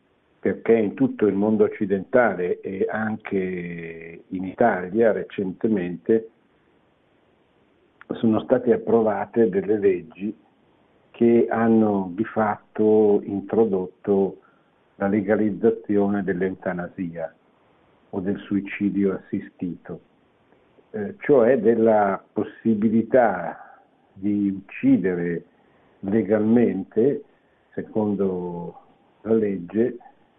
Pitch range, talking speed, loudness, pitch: 95-115 Hz, 75 wpm, -22 LUFS, 105 Hz